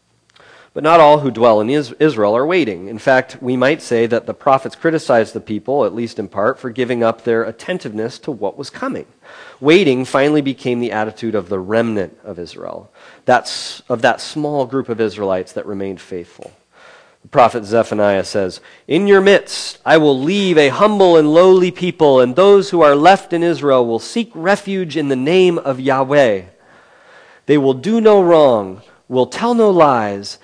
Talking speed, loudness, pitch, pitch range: 180 wpm, -14 LUFS, 130 Hz, 115-165 Hz